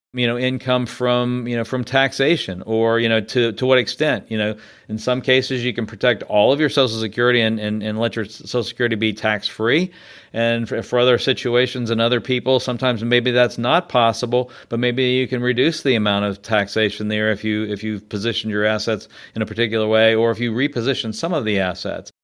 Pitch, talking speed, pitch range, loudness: 115 Hz, 215 wpm, 110-125 Hz, -19 LUFS